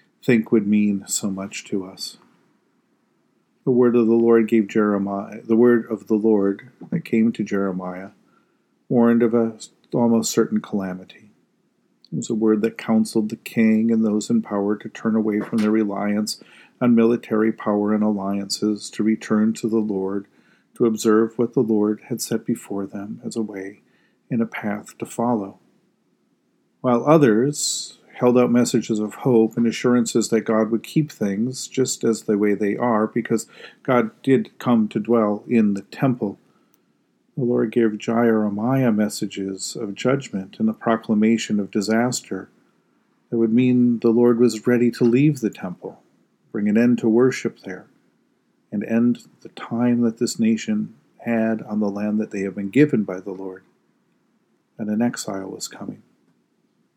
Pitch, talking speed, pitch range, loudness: 110 Hz, 165 wpm, 105-120 Hz, -21 LUFS